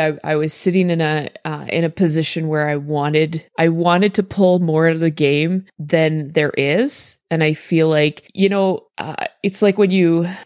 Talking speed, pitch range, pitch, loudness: 210 wpm, 155-185 Hz, 165 Hz, -17 LUFS